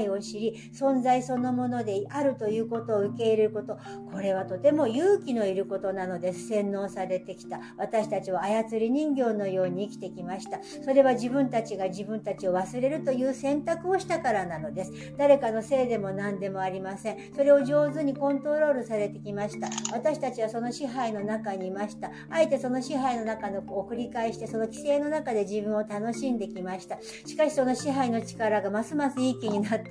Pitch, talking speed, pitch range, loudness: 225 Hz, 410 characters per minute, 200-270 Hz, -28 LUFS